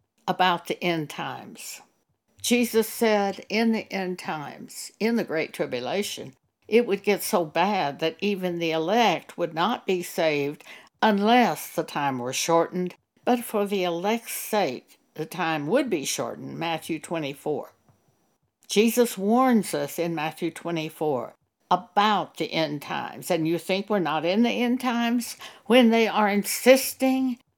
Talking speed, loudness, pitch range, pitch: 145 wpm, -25 LUFS, 165-225 Hz, 185 Hz